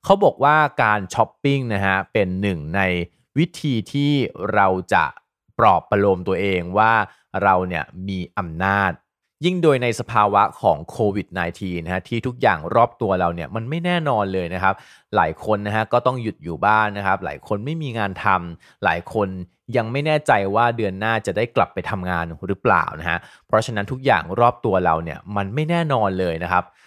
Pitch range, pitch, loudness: 95-120 Hz, 100 Hz, -20 LUFS